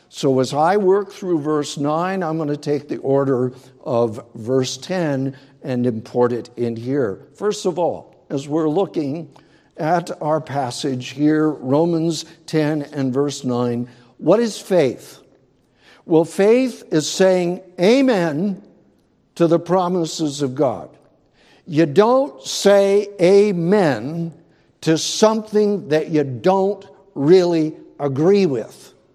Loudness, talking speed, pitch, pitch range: -19 LUFS, 125 wpm, 160 Hz, 140-185 Hz